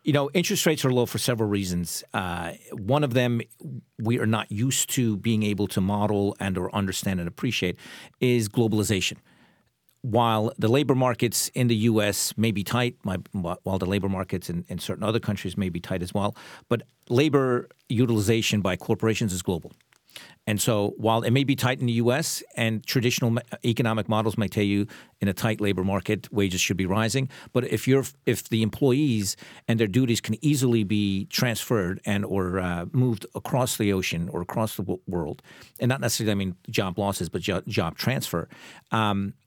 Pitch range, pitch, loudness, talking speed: 100-120 Hz, 110 Hz, -25 LUFS, 185 wpm